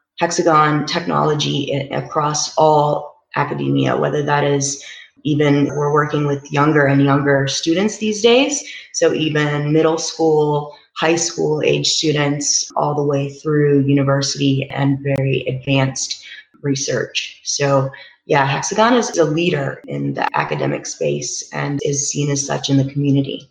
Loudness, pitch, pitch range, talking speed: -17 LUFS, 145 Hz, 140-155 Hz, 135 wpm